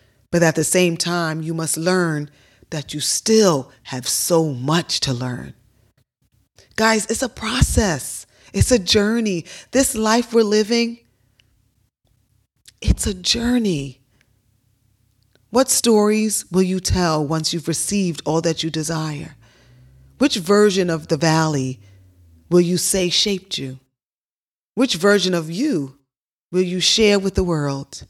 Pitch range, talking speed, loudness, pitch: 130-200 Hz, 130 wpm, -19 LUFS, 165 Hz